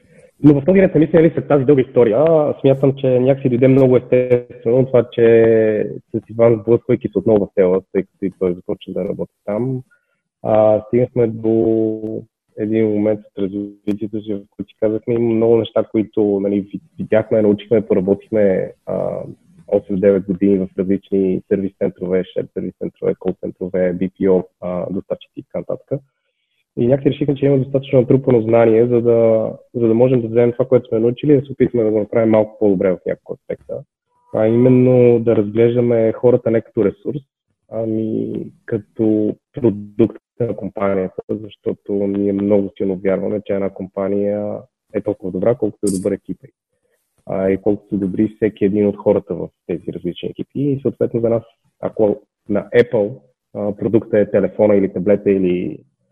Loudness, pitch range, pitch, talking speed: -17 LUFS, 100-125 Hz, 110 Hz, 165 wpm